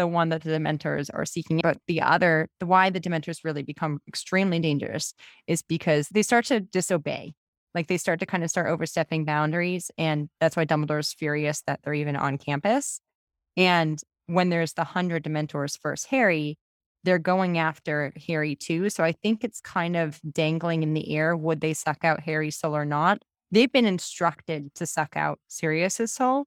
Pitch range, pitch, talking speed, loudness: 155-180 Hz, 165 Hz, 190 wpm, -26 LUFS